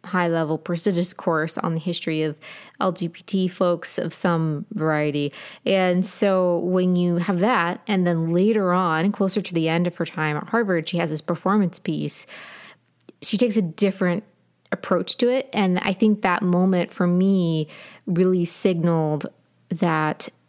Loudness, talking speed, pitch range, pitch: -22 LUFS, 160 wpm, 165-195 Hz, 180 Hz